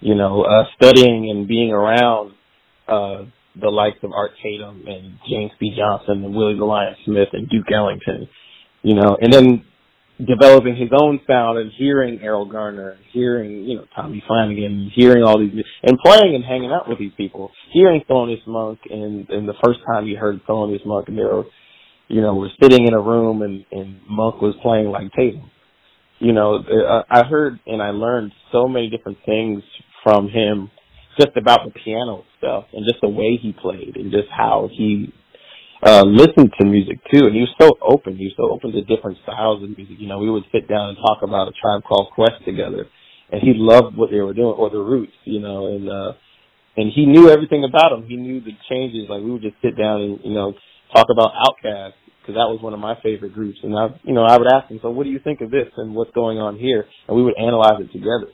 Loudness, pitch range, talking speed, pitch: -15 LUFS, 105-120 Hz, 220 wpm, 110 Hz